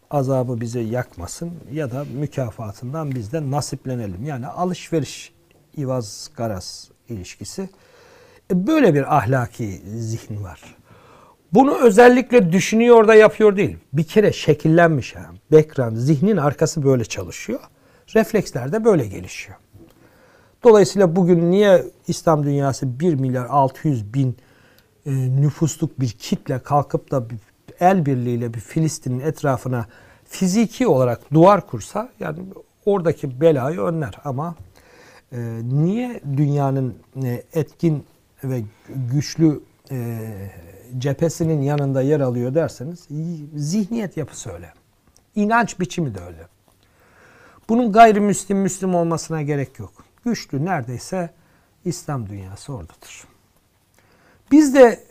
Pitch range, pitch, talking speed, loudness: 120-170 Hz, 145 Hz, 105 wpm, -19 LUFS